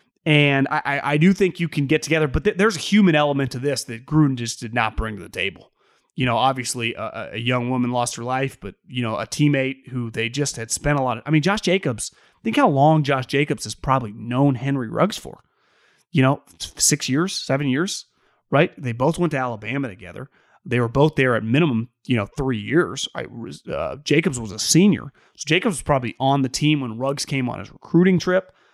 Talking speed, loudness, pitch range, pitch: 225 wpm, -21 LUFS, 125-155 Hz, 135 Hz